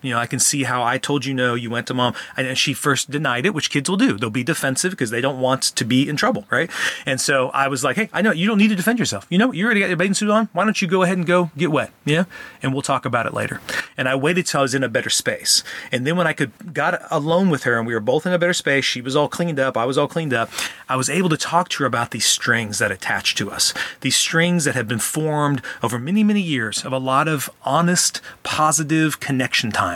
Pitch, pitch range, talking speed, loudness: 145 Hz, 130-175 Hz, 285 wpm, -19 LUFS